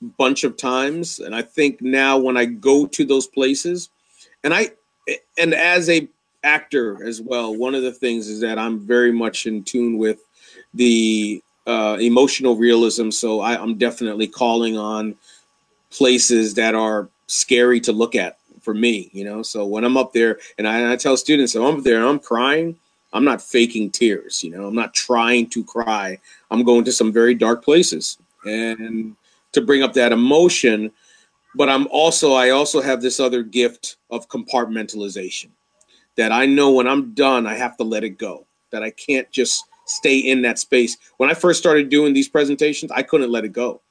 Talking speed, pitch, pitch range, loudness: 190 wpm, 120 Hz, 115-135 Hz, -18 LUFS